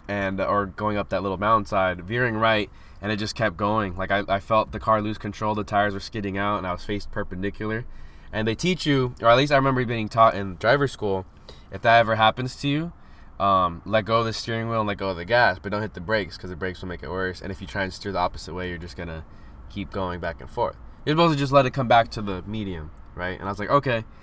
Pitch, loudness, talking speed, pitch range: 105 Hz, -24 LUFS, 275 wpm, 95-115 Hz